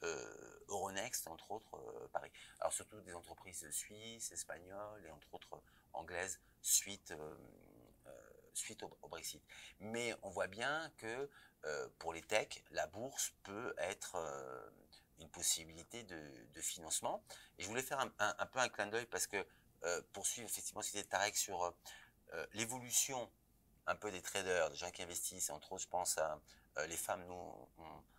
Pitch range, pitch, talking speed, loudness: 85-120 Hz, 100 Hz, 175 wpm, -42 LUFS